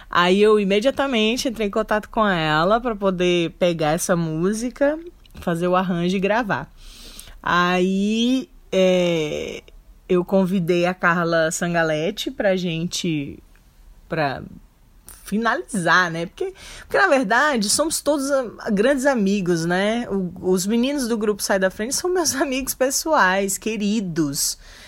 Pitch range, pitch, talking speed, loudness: 175-235 Hz, 195 Hz, 125 wpm, -20 LUFS